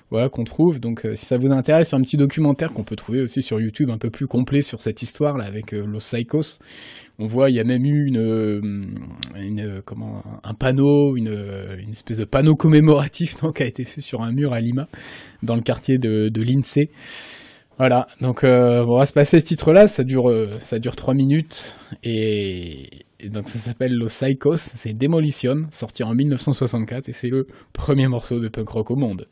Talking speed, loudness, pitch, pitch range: 205 wpm, -20 LUFS, 125 Hz, 110-140 Hz